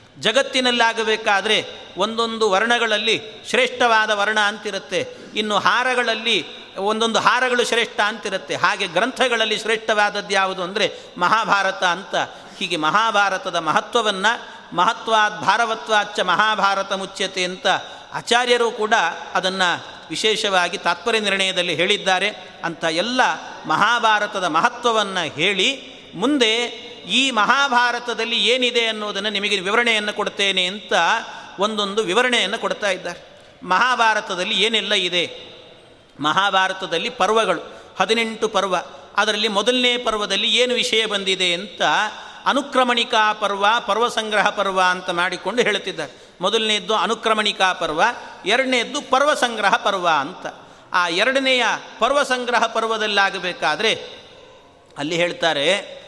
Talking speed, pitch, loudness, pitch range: 95 wpm, 215 Hz, -19 LUFS, 190-235 Hz